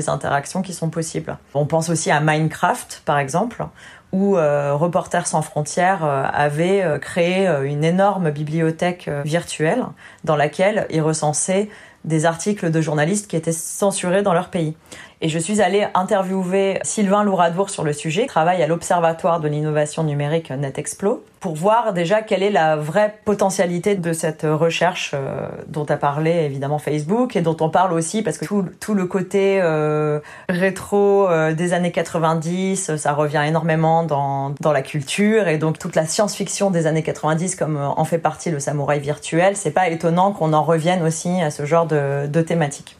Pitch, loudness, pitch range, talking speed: 165 Hz, -19 LUFS, 155-190 Hz, 170 wpm